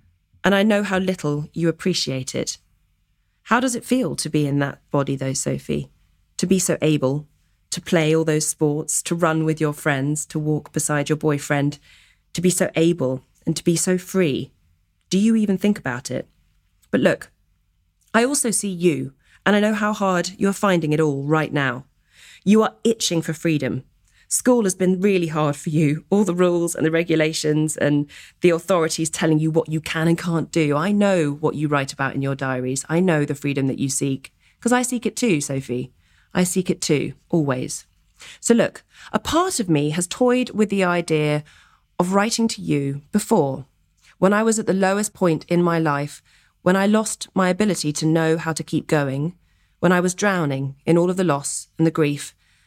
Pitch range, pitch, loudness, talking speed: 145-185 Hz, 160 Hz, -21 LUFS, 200 wpm